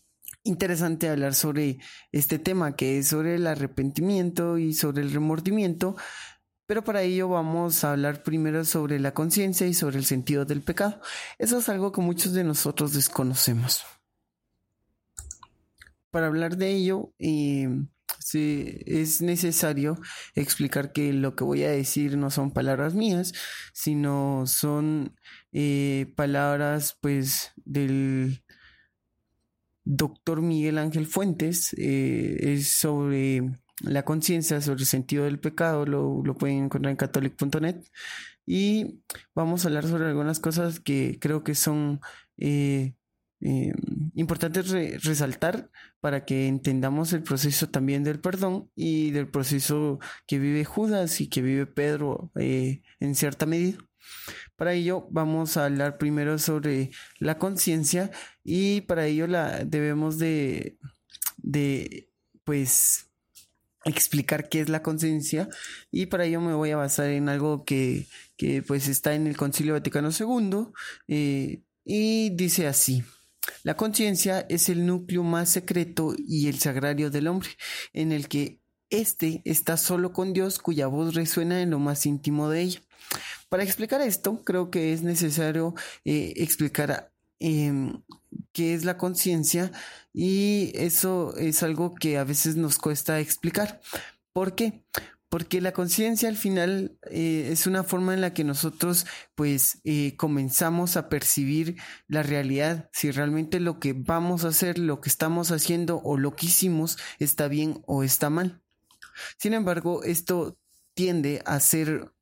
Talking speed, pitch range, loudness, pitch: 140 wpm, 145-175 Hz, -26 LUFS, 155 Hz